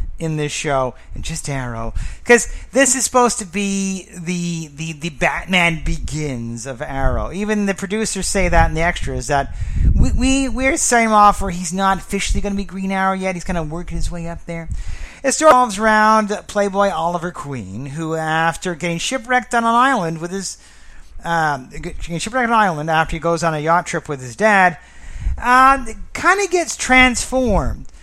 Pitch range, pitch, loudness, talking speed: 155-215 Hz, 175 Hz, -17 LUFS, 185 wpm